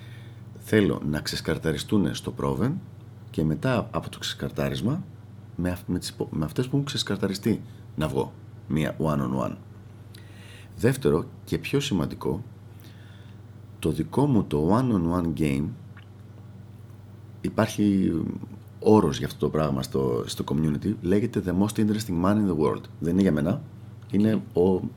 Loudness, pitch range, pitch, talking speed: -26 LUFS, 80-110 Hz, 105 Hz, 125 wpm